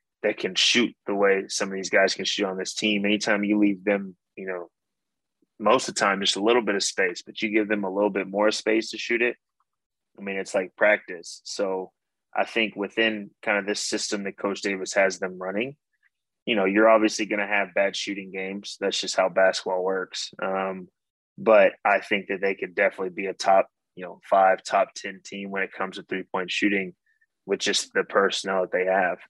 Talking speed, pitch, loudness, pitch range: 220 wpm, 100 Hz, -24 LUFS, 95-105 Hz